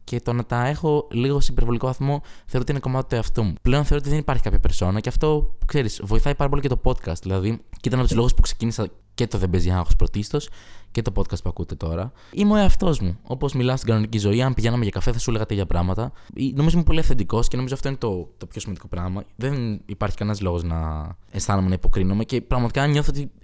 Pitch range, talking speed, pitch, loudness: 100-130 Hz, 240 wpm, 115 Hz, -24 LUFS